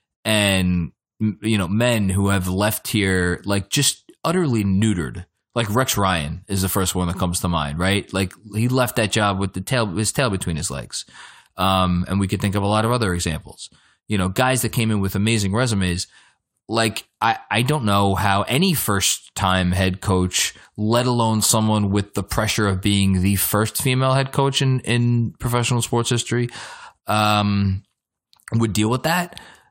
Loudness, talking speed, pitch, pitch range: -20 LUFS, 185 wpm, 105 Hz, 95-120 Hz